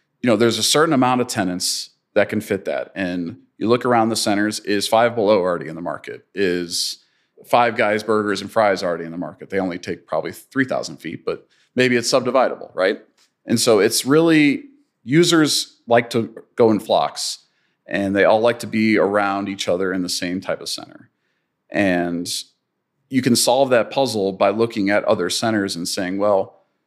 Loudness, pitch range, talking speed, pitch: -19 LUFS, 95-120 Hz, 190 wpm, 110 Hz